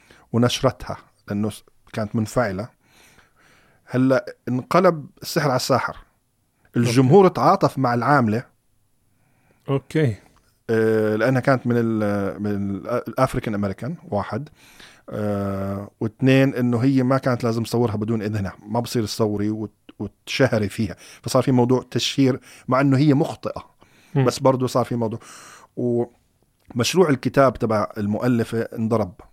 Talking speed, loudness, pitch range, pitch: 110 wpm, -21 LUFS, 105-130 Hz, 120 Hz